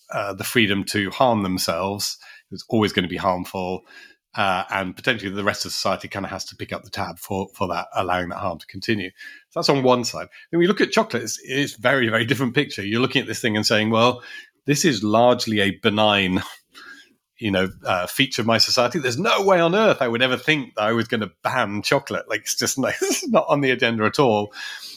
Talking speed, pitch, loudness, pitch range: 240 wpm, 115 Hz, -21 LUFS, 100-135 Hz